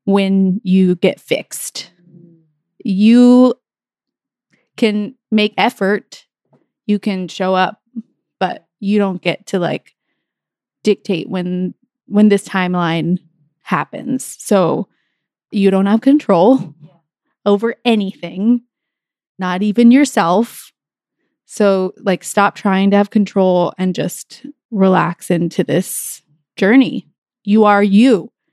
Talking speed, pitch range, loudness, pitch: 105 wpm, 180-230 Hz, -15 LUFS, 200 Hz